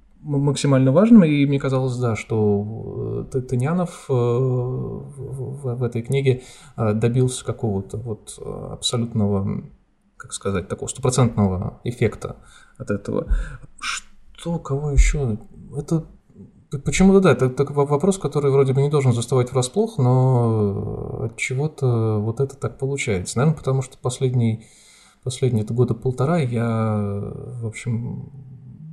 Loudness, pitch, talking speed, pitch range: -21 LUFS, 130 Hz, 115 wpm, 115-140 Hz